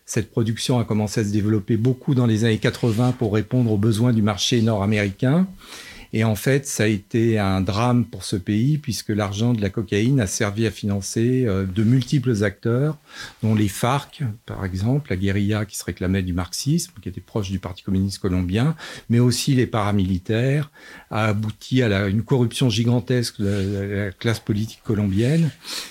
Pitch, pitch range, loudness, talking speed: 110 Hz, 105-125 Hz, -22 LUFS, 185 wpm